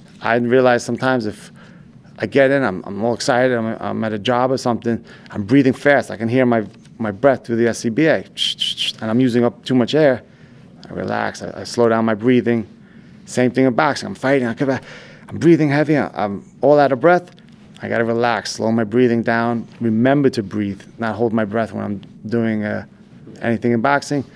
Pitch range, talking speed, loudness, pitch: 110-130 Hz, 200 wpm, -18 LUFS, 120 Hz